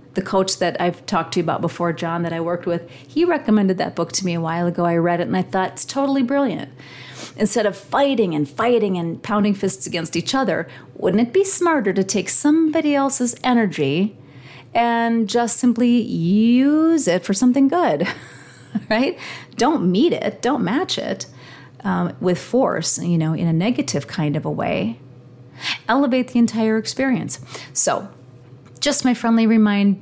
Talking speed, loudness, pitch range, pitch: 175 wpm, -19 LUFS, 170-240 Hz, 195 Hz